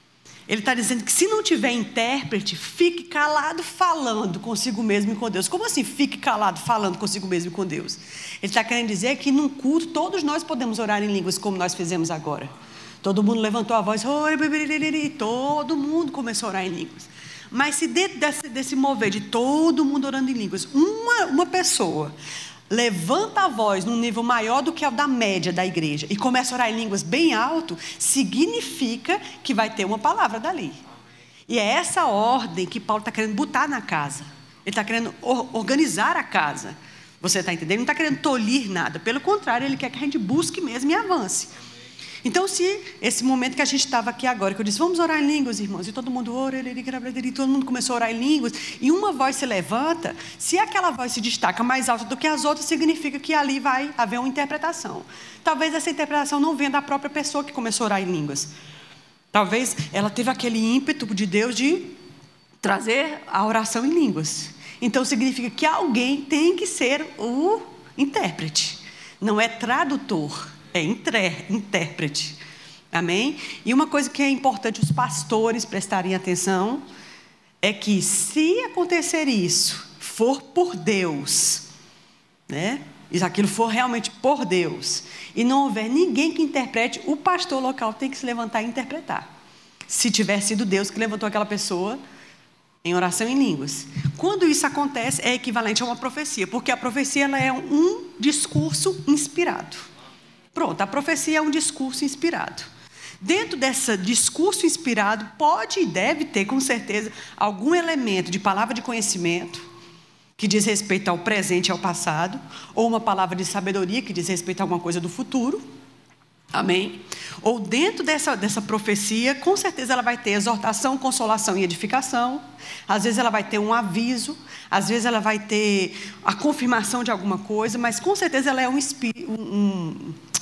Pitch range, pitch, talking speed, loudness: 200-290 Hz, 240 Hz, 175 wpm, -23 LUFS